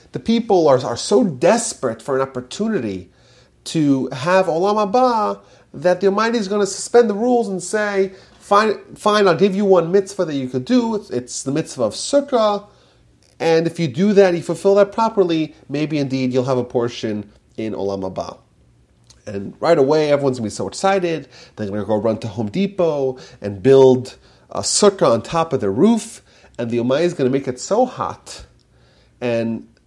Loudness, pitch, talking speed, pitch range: -18 LUFS, 155 Hz, 185 wpm, 125-200 Hz